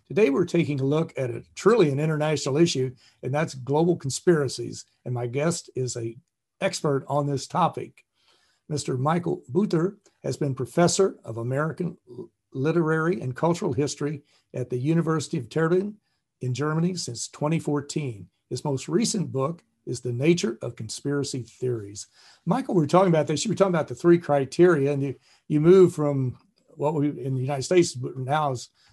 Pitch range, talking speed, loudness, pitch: 130-170 Hz, 170 wpm, -25 LUFS, 145 Hz